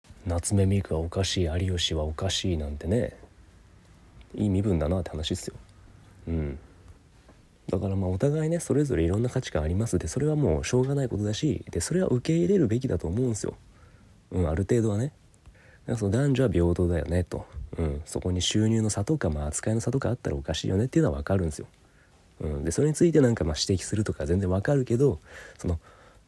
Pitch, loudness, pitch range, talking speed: 95 Hz, -27 LUFS, 85-120 Hz, 420 characters per minute